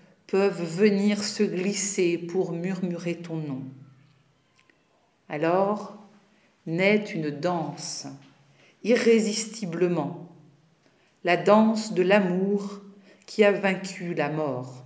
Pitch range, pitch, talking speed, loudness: 160-200 Hz, 180 Hz, 90 wpm, -25 LUFS